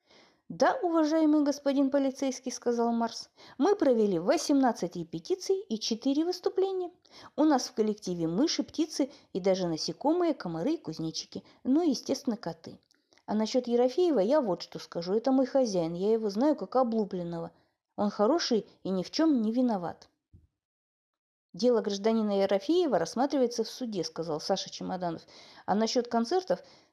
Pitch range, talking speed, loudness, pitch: 195-290 Hz, 145 wpm, -29 LUFS, 245 Hz